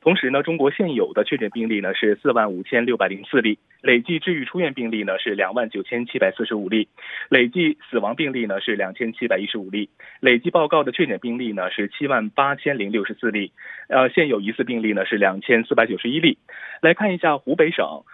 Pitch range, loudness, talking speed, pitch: 105-135 Hz, -21 LUFS, 340 characters per minute, 115 Hz